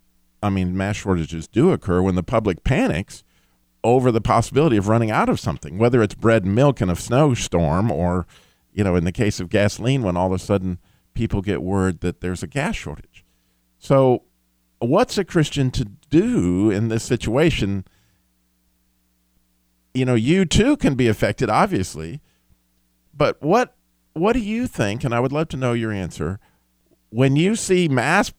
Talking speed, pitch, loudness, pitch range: 175 wpm, 100 Hz, -20 LUFS, 80-125 Hz